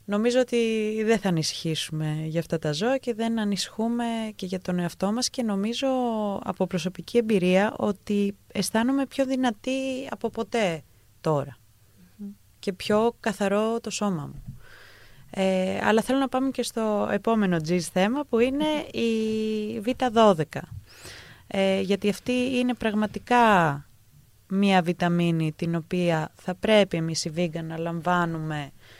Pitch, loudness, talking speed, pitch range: 200 Hz, -25 LUFS, 135 wpm, 170-230 Hz